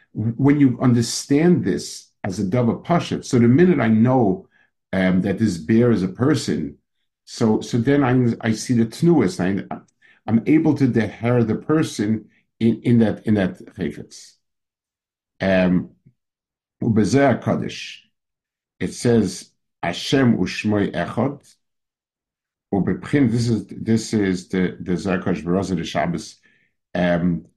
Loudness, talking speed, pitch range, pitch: -20 LUFS, 120 wpm, 95-125 Hz, 115 Hz